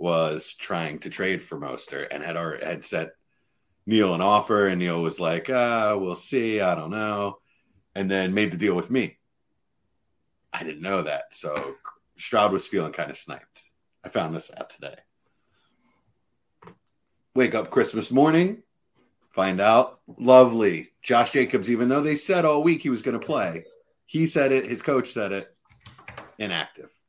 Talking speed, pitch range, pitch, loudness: 165 wpm, 100-140 Hz, 120 Hz, -24 LUFS